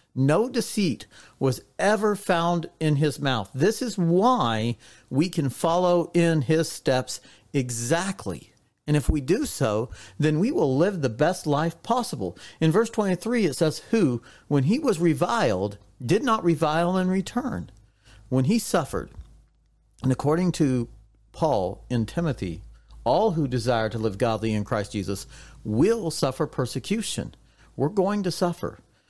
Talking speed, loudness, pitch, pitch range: 145 wpm, -25 LUFS, 155 Hz, 120-180 Hz